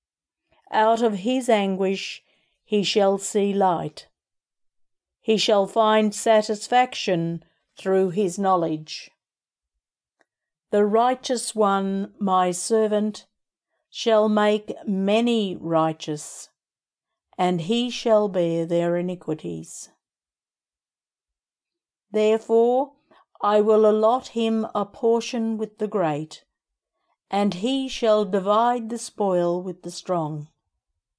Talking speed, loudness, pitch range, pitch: 95 wpm, -22 LUFS, 180-225 Hz, 210 Hz